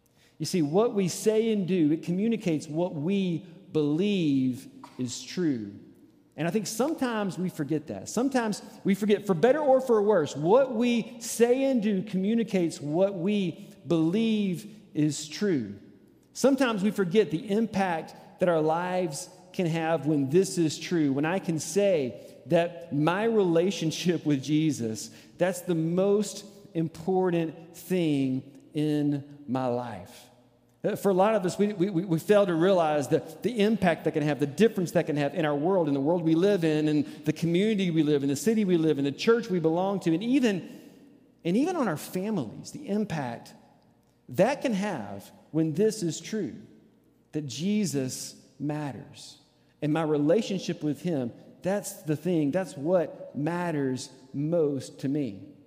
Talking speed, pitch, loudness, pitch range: 165 wpm, 170 Hz, -27 LUFS, 150-200 Hz